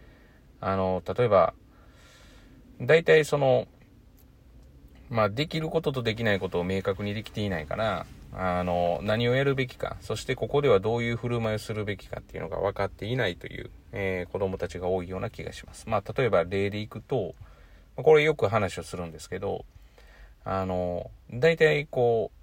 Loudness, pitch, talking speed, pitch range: -27 LUFS, 105 Hz, 340 characters per minute, 90-125 Hz